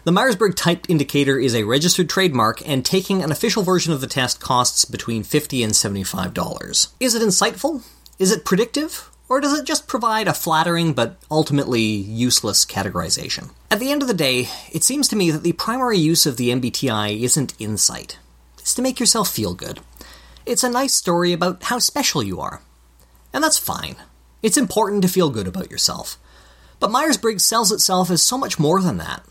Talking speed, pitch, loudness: 190 wpm, 170 Hz, -18 LUFS